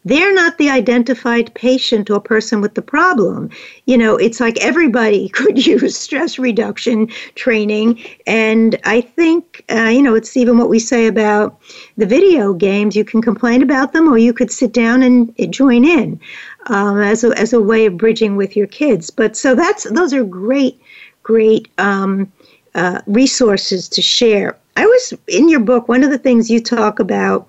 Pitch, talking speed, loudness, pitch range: 235 Hz, 185 wpm, -13 LUFS, 220-260 Hz